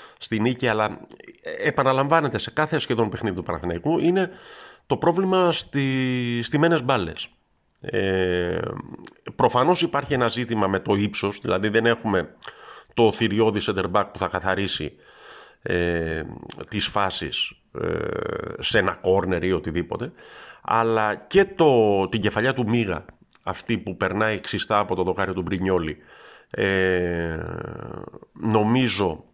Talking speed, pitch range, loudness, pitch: 125 wpm, 95-130 Hz, -23 LUFS, 110 Hz